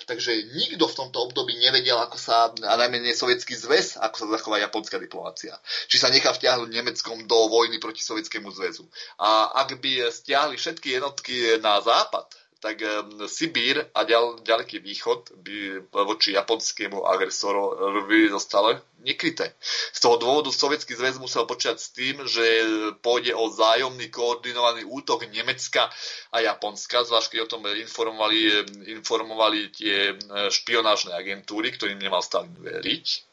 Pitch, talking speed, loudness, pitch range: 115 Hz, 140 wpm, -23 LUFS, 105-125 Hz